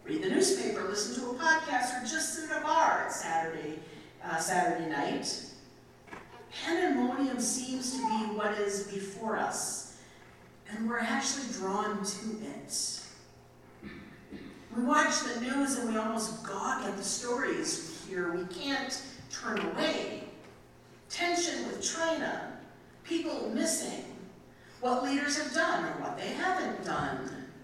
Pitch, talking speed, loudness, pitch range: 250 Hz, 135 wpm, -32 LUFS, 210-315 Hz